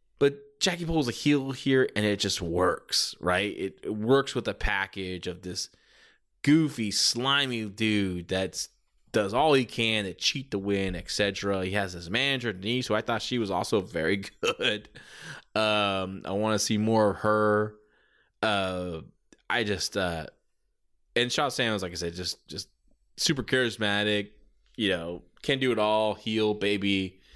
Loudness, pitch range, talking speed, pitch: -27 LUFS, 95-120 Hz, 165 wpm, 105 Hz